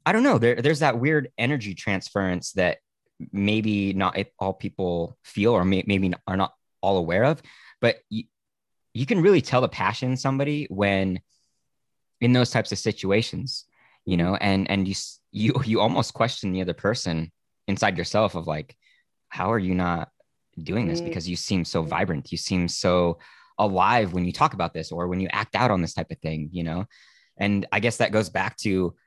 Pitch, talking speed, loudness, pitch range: 100 Hz, 195 wpm, -24 LUFS, 90-110 Hz